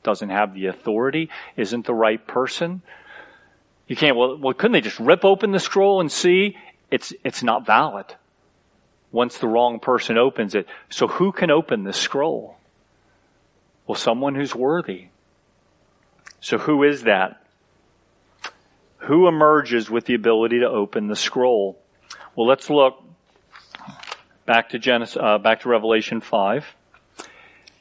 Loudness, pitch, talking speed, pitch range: -20 LUFS, 120 Hz, 140 wpm, 110-150 Hz